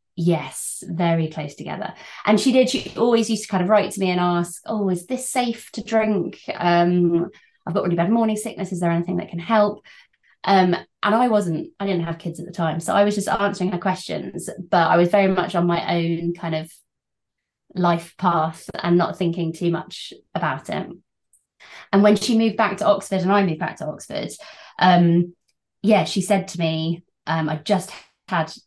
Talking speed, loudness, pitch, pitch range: 205 wpm, -21 LUFS, 180 Hz, 170-205 Hz